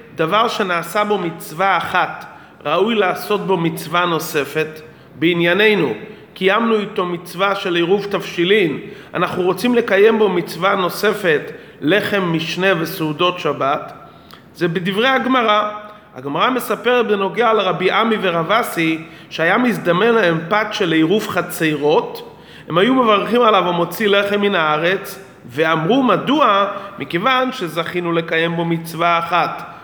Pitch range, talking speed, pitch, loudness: 170-210 Hz, 120 wpm, 190 Hz, -17 LUFS